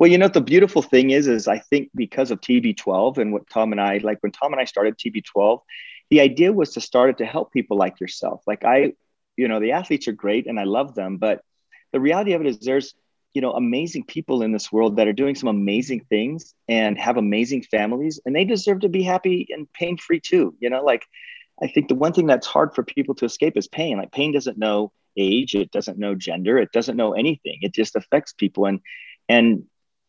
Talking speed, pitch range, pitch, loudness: 230 wpm, 105-160 Hz, 125 Hz, -21 LUFS